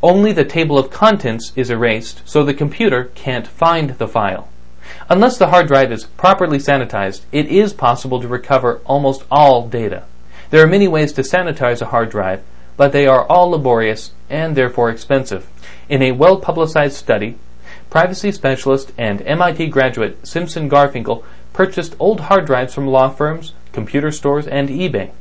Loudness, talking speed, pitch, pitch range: -14 LUFS, 160 wpm, 135 Hz, 120-160 Hz